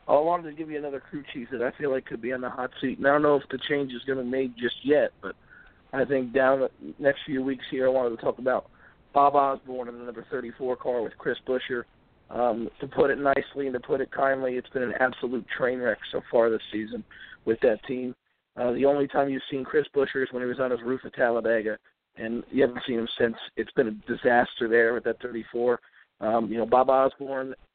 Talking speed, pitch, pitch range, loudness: 250 wpm, 130 Hz, 120-135 Hz, -27 LUFS